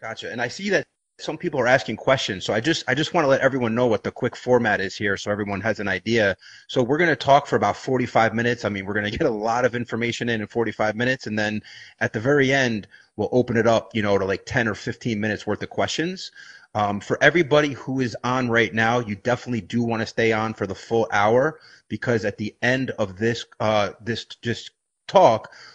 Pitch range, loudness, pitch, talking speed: 105-125 Hz, -22 LUFS, 115 Hz, 240 wpm